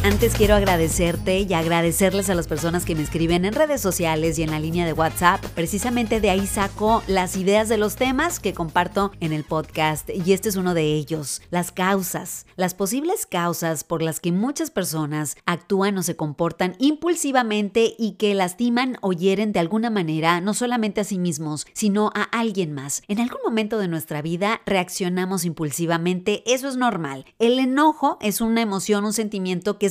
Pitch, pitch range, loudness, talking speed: 190 Hz, 170-215 Hz, -22 LUFS, 185 wpm